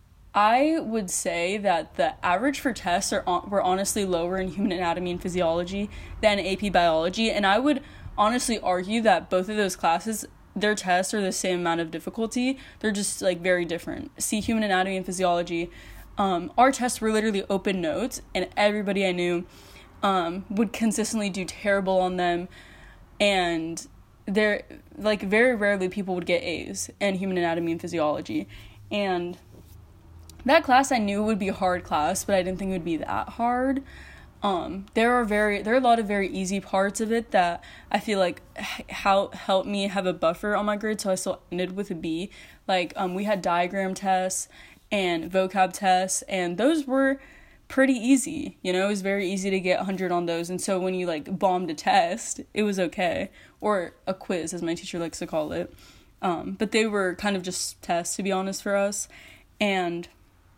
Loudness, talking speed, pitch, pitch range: -25 LUFS, 190 wpm, 195 Hz, 180-215 Hz